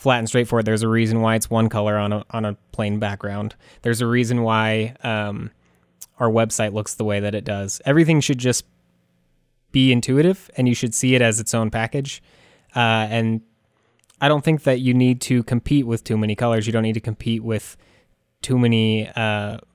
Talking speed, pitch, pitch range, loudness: 200 wpm, 115 Hz, 105-125 Hz, -20 LUFS